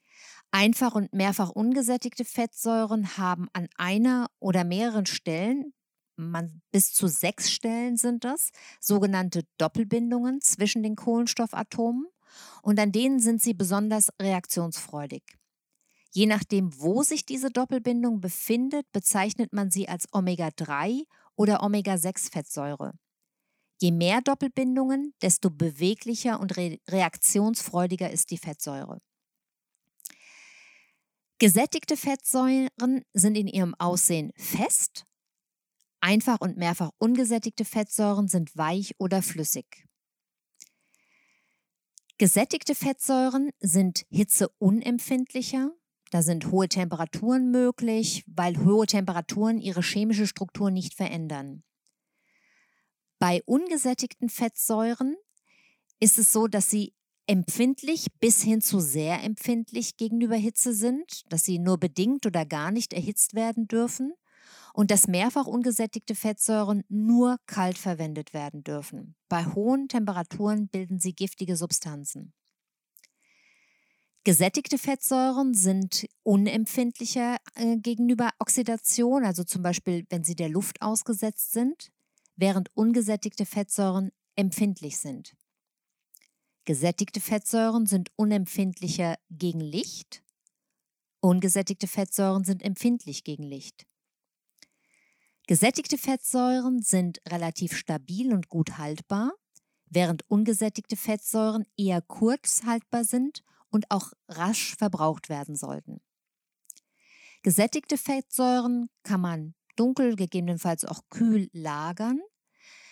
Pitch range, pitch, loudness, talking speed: 180-240 Hz, 210 Hz, -26 LUFS, 105 wpm